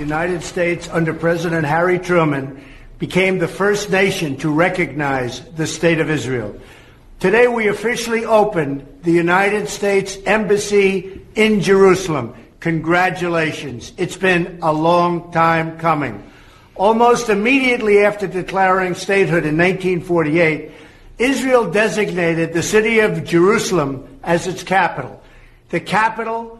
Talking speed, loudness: 115 wpm, -16 LUFS